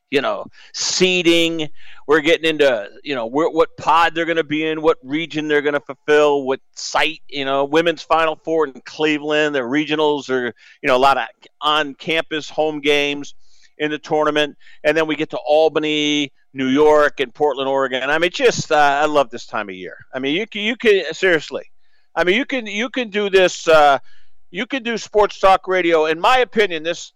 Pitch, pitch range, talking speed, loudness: 155 Hz, 145-175 Hz, 205 wpm, -18 LUFS